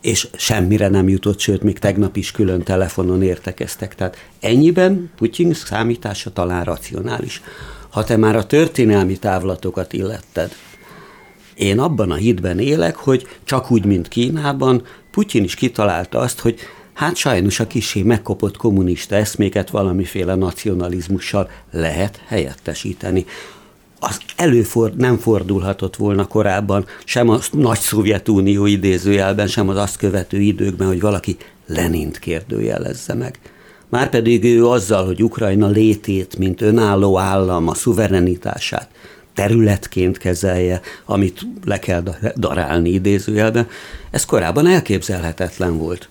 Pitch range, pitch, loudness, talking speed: 95-115 Hz, 100 Hz, -17 LUFS, 120 wpm